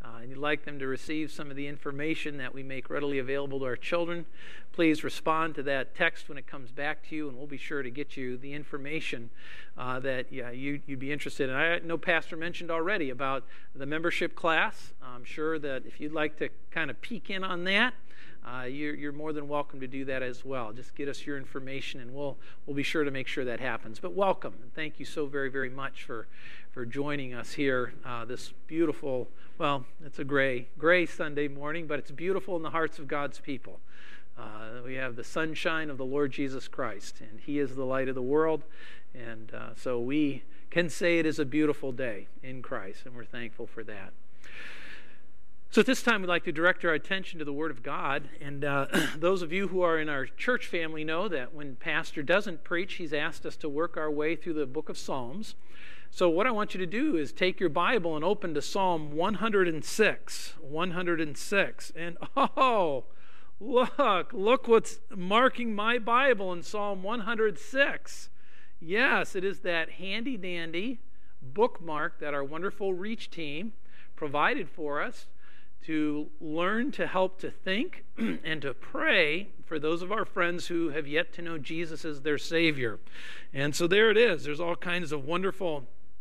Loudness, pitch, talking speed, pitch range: -30 LUFS, 155 Hz, 200 wpm, 140-175 Hz